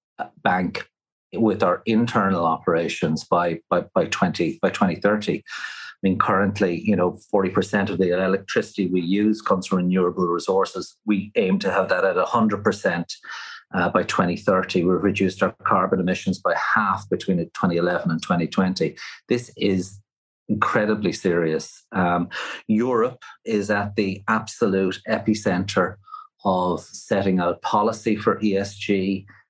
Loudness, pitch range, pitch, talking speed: -22 LUFS, 90-105 Hz, 100 Hz, 130 wpm